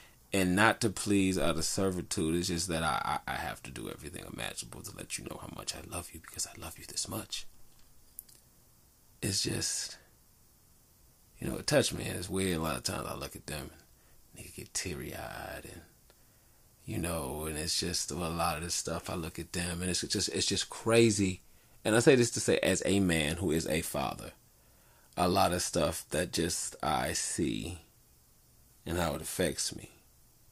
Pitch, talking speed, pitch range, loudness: 85 Hz, 205 wpm, 80-95 Hz, -32 LUFS